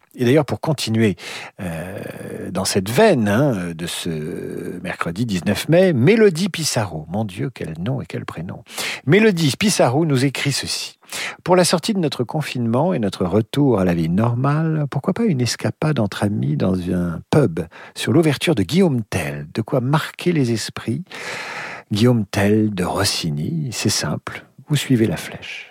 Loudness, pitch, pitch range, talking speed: -19 LUFS, 125 Hz, 105-160 Hz, 165 wpm